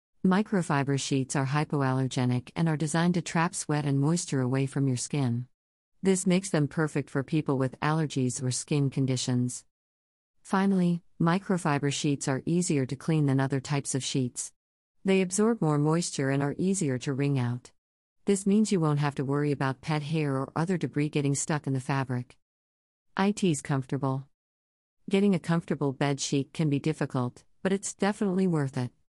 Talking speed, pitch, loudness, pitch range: 170 wpm, 145 Hz, -28 LUFS, 130-165 Hz